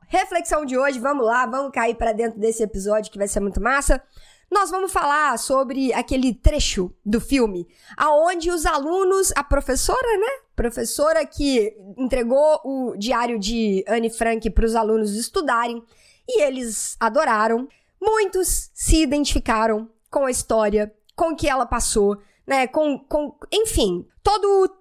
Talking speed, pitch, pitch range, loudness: 150 wpm, 255 Hz, 225-310 Hz, -21 LUFS